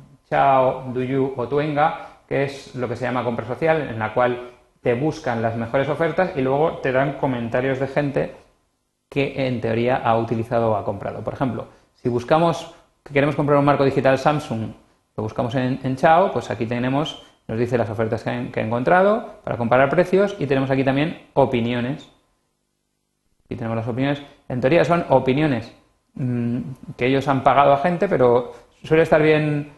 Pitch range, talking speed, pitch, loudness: 120-145 Hz, 180 wpm, 135 Hz, -21 LUFS